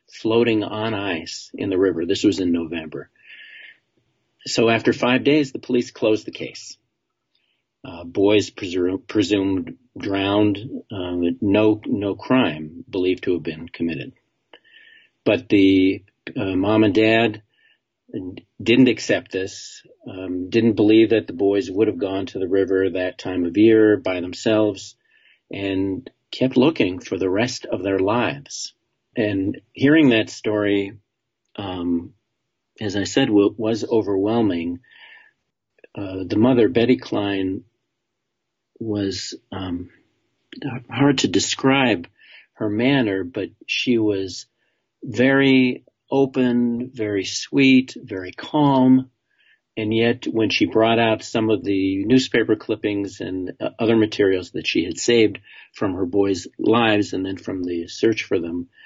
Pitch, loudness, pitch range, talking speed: 105 Hz, -20 LUFS, 95-115 Hz, 135 wpm